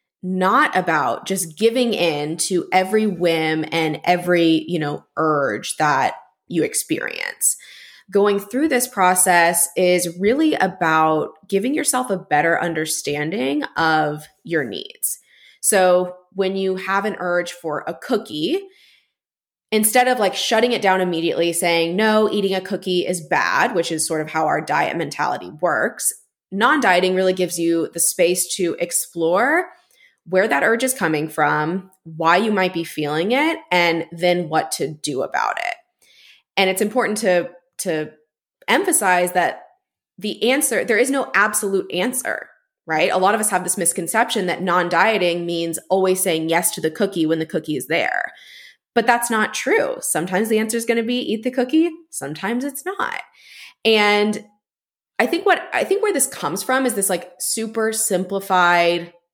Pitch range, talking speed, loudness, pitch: 170-230 Hz, 160 wpm, -19 LUFS, 185 Hz